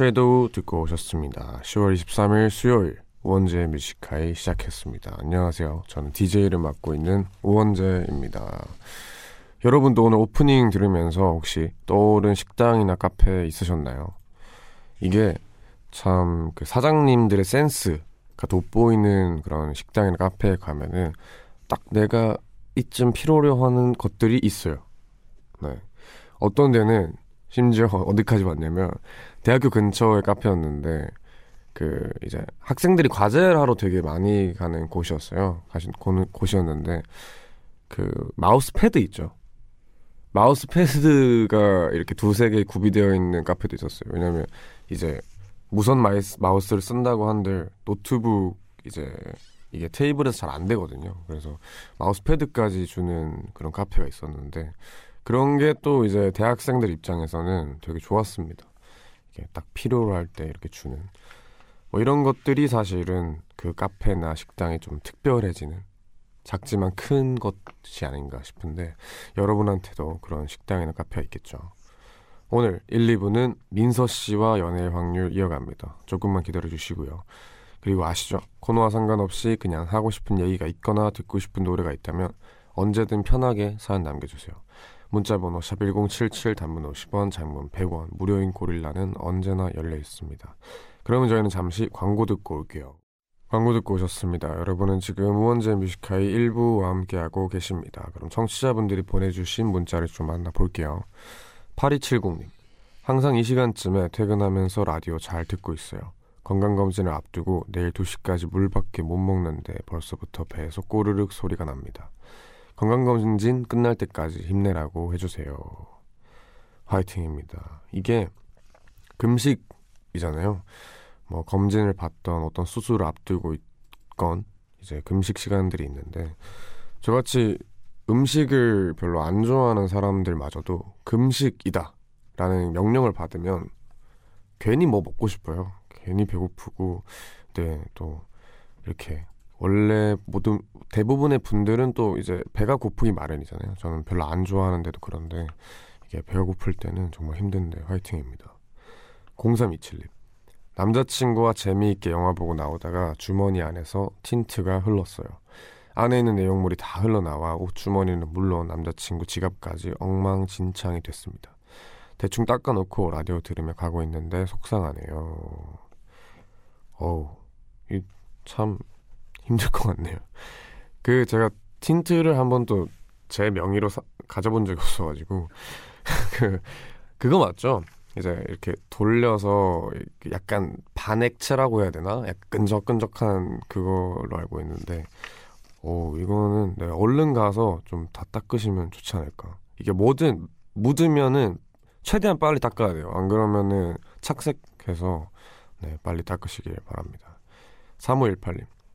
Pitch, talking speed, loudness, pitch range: 95 Hz, 290 characters per minute, -24 LUFS, 85-110 Hz